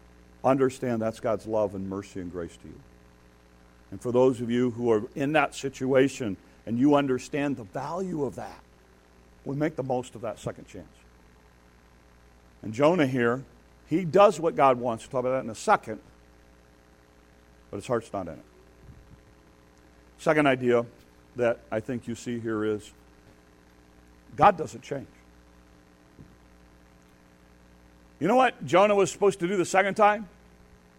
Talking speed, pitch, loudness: 155 wpm, 85 Hz, -26 LUFS